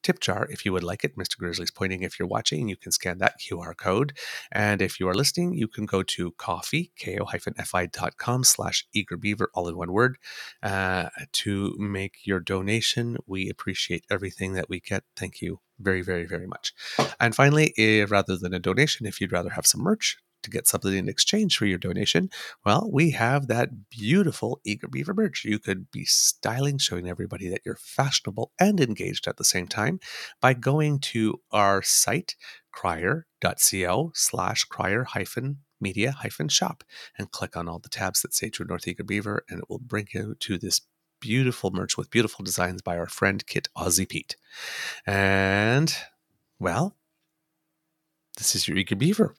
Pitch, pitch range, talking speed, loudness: 105 Hz, 95-140 Hz, 180 wpm, -25 LUFS